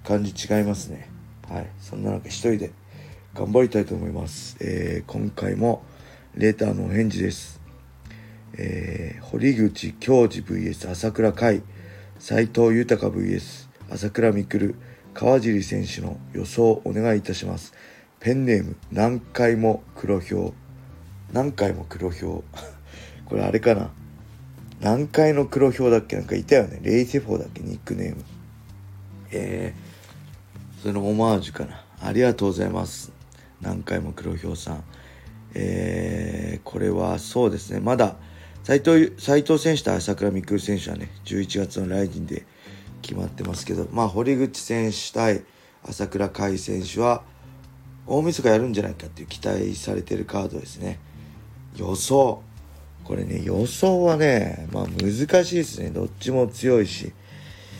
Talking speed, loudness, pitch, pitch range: 275 characters per minute, -23 LUFS, 105 Hz, 90-115 Hz